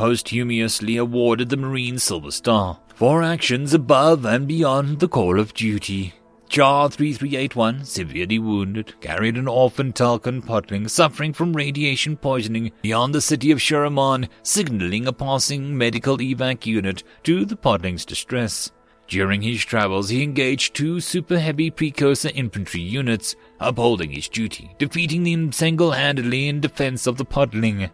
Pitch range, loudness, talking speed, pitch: 110-145 Hz, -20 LUFS, 135 wpm, 125 Hz